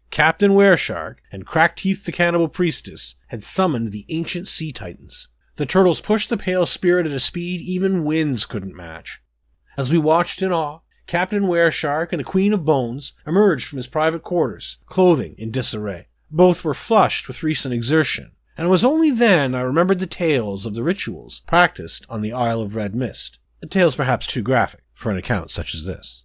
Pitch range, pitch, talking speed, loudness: 115-180 Hz, 155 Hz, 190 wpm, -19 LUFS